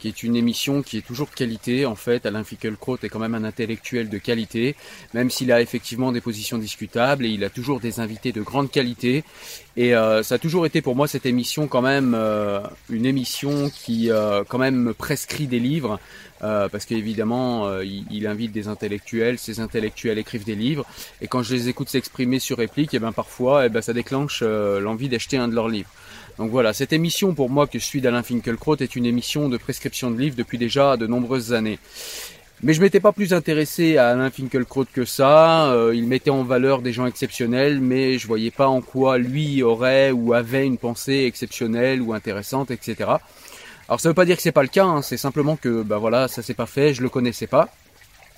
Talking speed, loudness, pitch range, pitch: 215 wpm, -21 LUFS, 115-135 Hz, 125 Hz